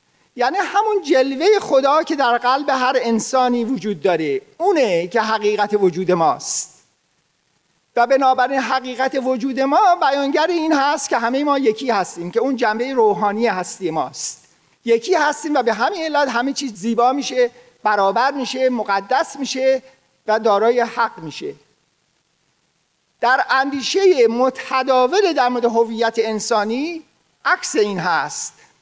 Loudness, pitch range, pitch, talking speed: -18 LUFS, 230-285 Hz, 255 Hz, 130 wpm